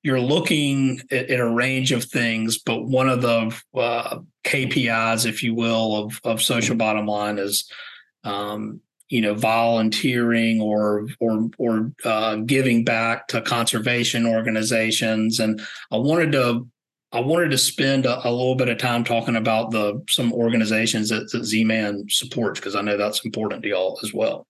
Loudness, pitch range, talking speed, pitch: -21 LUFS, 110-125 Hz, 170 wpm, 115 Hz